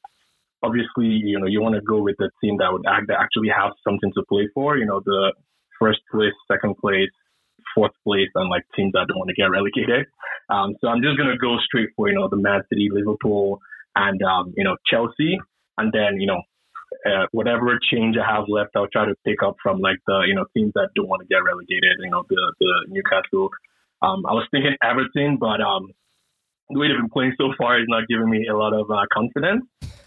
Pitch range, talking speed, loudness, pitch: 105-140 Hz, 225 wpm, -21 LUFS, 110 Hz